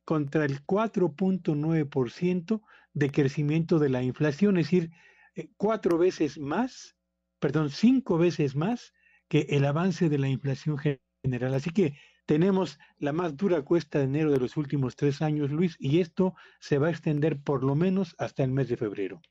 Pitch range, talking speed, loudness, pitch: 145-180 Hz, 170 wpm, -27 LUFS, 155 Hz